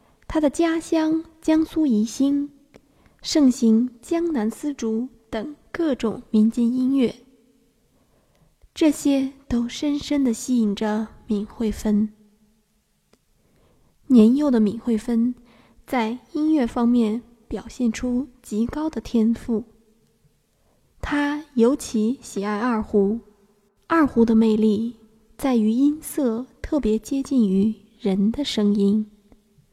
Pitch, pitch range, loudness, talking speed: 235 Hz, 220-275 Hz, -22 LUFS, 155 characters per minute